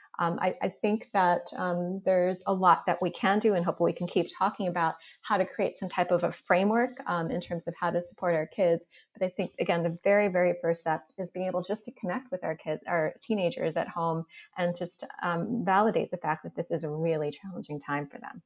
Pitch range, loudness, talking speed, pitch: 170-195 Hz, -29 LUFS, 240 wpm, 180 Hz